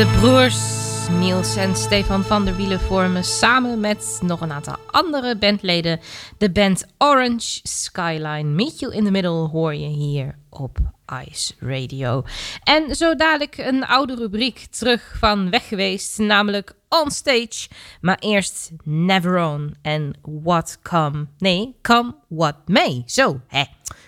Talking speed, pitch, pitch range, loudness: 135 wpm, 175 Hz, 145-220 Hz, -19 LUFS